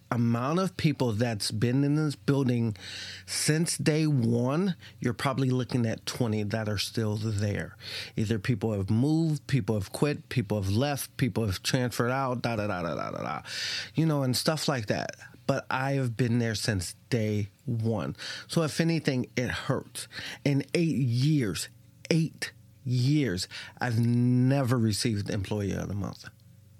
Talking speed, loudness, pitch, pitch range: 160 wpm, -29 LUFS, 120 Hz, 110-140 Hz